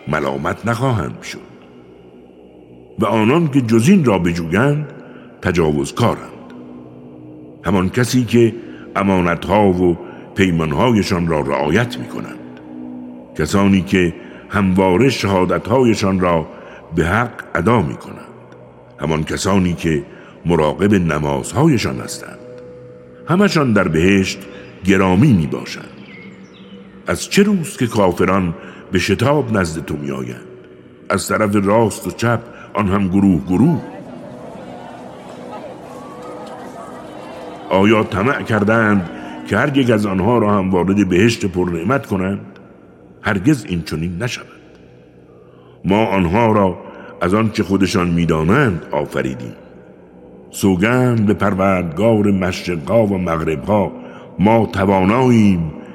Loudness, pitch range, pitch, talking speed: -16 LUFS, 60-105 Hz, 90 Hz, 100 wpm